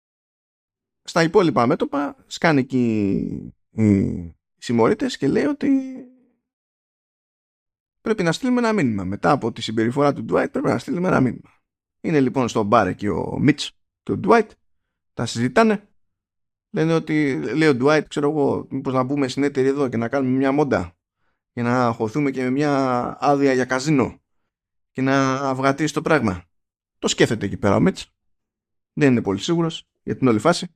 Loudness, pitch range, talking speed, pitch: -20 LUFS, 110-150 Hz, 165 wpm, 135 Hz